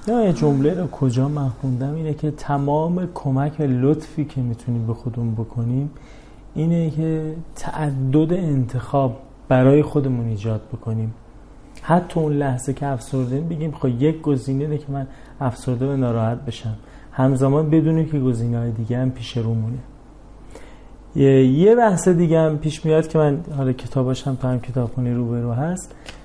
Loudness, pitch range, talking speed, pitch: -21 LUFS, 125-155 Hz, 155 wpm, 135 Hz